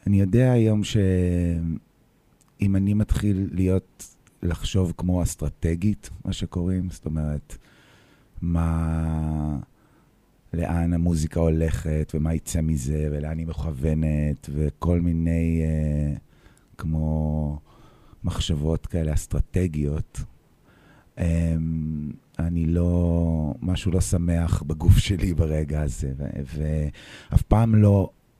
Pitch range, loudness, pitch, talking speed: 75-90 Hz, -24 LUFS, 85 Hz, 90 wpm